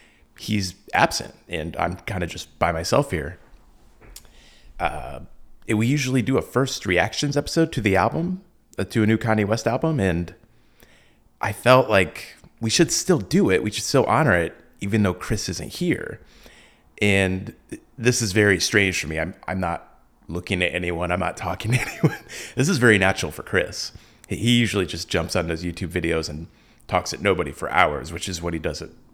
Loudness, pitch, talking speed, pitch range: -22 LUFS, 100 Hz, 185 wpm, 90-115 Hz